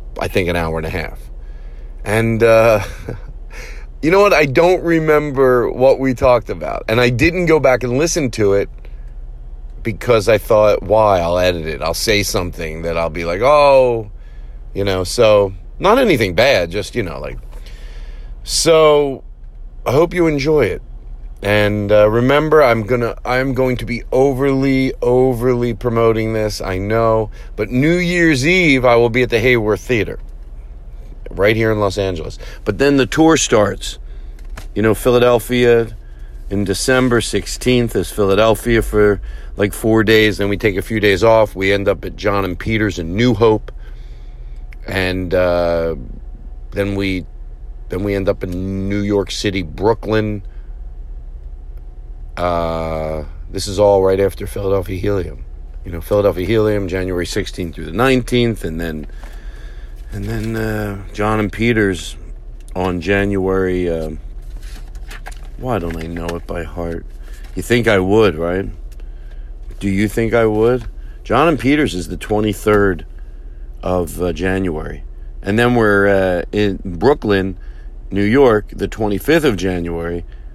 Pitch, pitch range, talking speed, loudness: 100 Hz, 85-115 Hz, 150 wpm, -15 LUFS